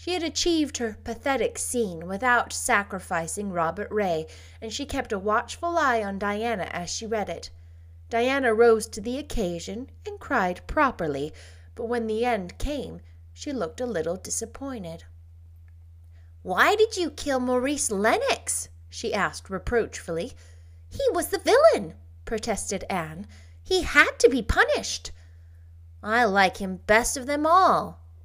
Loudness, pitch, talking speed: -25 LUFS, 205 Hz, 140 wpm